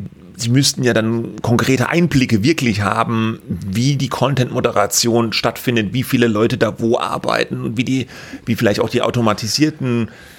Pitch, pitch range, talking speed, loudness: 120 Hz, 115-130 Hz, 155 wpm, -17 LUFS